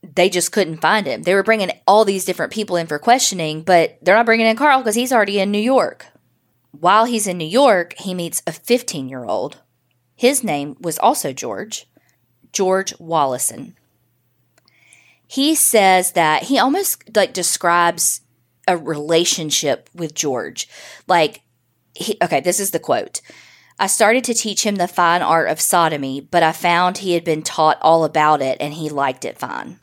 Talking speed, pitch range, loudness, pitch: 175 wpm, 150-200 Hz, -17 LUFS, 175 Hz